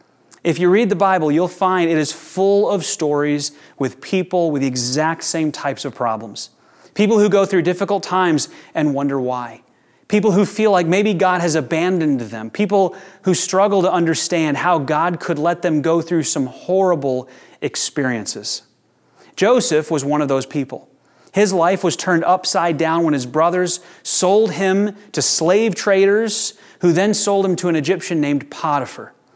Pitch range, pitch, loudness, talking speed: 150-190 Hz, 175 Hz, -18 LUFS, 170 wpm